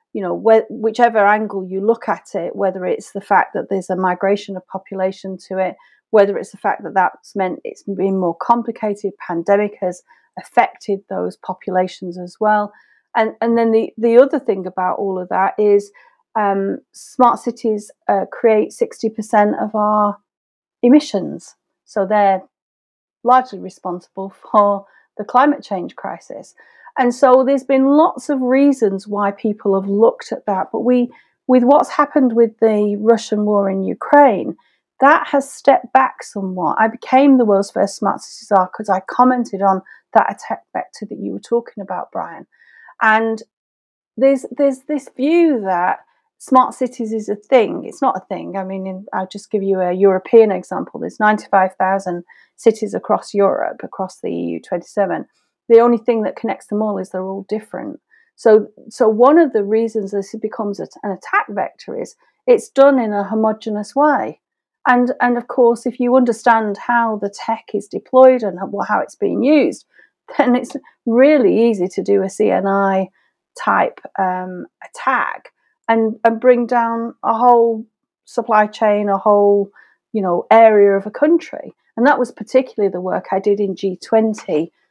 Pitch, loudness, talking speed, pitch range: 215 Hz, -16 LUFS, 165 wpm, 195-245 Hz